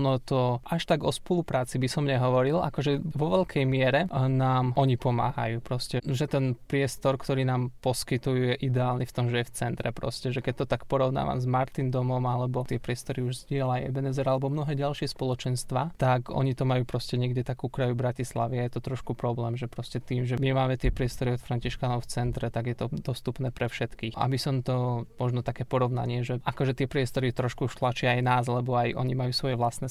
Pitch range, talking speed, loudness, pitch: 125-135 Hz, 205 wpm, -28 LUFS, 130 Hz